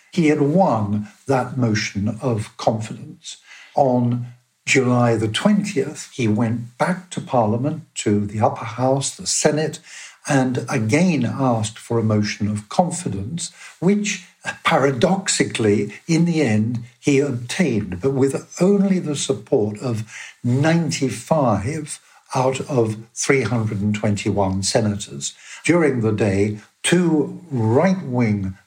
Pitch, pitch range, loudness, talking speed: 125 Hz, 110-155 Hz, -20 LUFS, 115 wpm